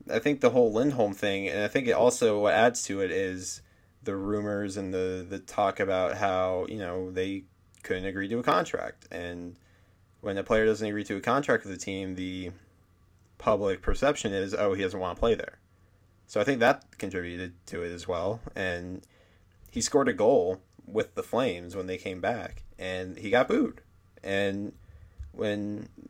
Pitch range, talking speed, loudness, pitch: 90-100 Hz, 185 wpm, -29 LUFS, 95 Hz